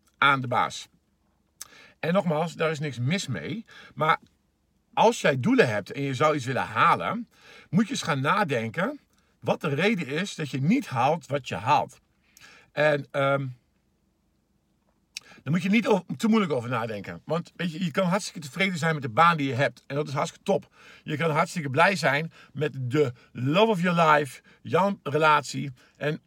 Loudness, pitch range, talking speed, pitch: -25 LUFS, 145-190 Hz, 185 wpm, 155 Hz